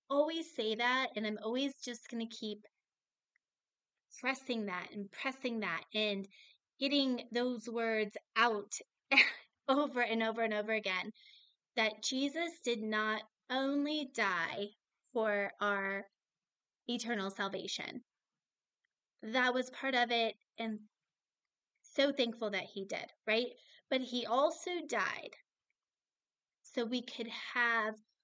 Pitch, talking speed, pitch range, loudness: 230 Hz, 120 wpm, 215-255 Hz, -36 LUFS